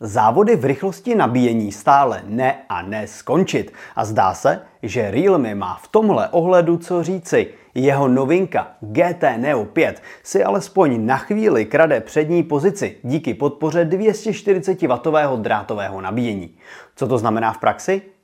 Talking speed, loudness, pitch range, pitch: 140 wpm, -18 LUFS, 125-190 Hz, 155 Hz